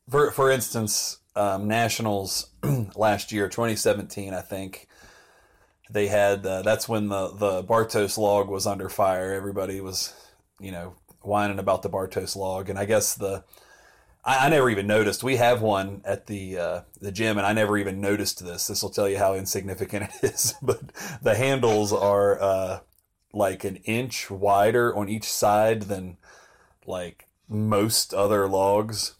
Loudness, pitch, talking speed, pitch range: -24 LUFS, 100 Hz, 160 wpm, 95-110 Hz